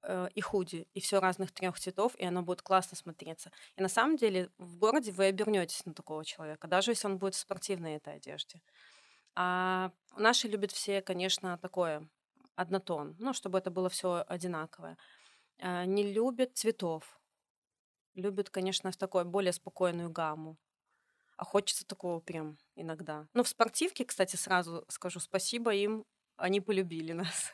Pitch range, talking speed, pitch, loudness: 175-205 Hz, 155 wpm, 185 Hz, -34 LUFS